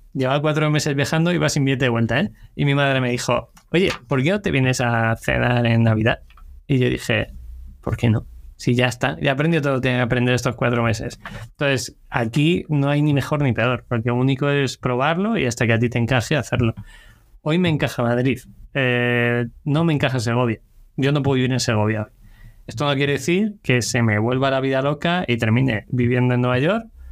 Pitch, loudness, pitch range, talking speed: 125 Hz, -20 LUFS, 115-145 Hz, 215 wpm